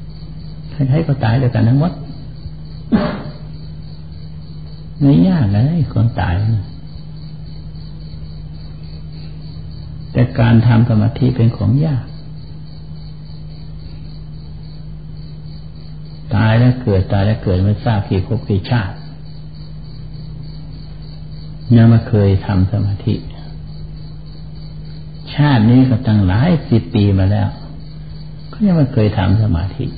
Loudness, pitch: -14 LUFS, 110 Hz